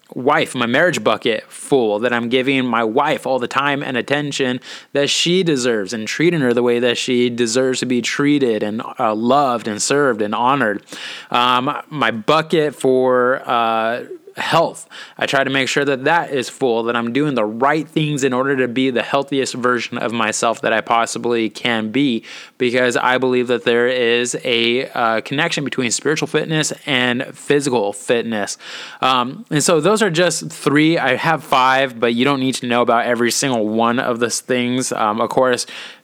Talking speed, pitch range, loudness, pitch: 185 wpm, 120-140 Hz, -17 LUFS, 130 Hz